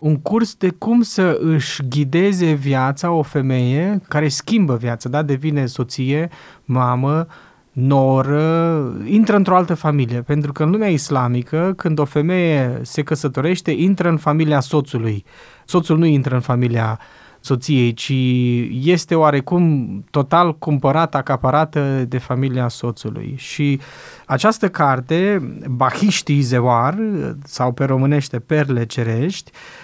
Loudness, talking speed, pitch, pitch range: -17 LUFS, 125 wpm, 145 Hz, 130-165 Hz